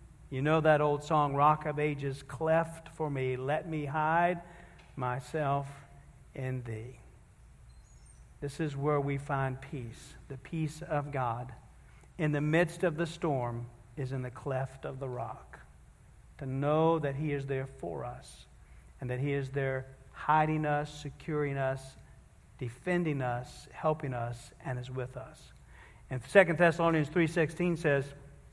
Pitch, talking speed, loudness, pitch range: 140 Hz, 145 wpm, -32 LUFS, 130-155 Hz